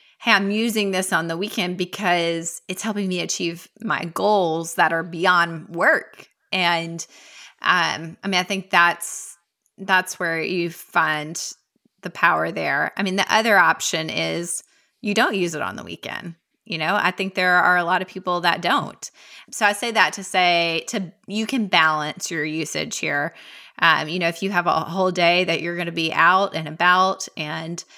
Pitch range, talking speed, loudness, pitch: 165-195 Hz, 190 wpm, -21 LUFS, 180 Hz